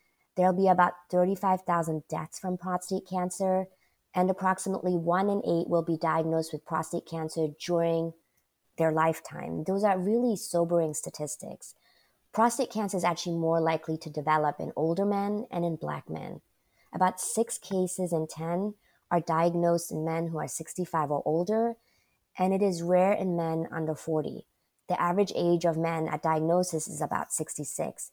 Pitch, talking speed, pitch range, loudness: 170 Hz, 160 wpm, 160-185 Hz, -29 LUFS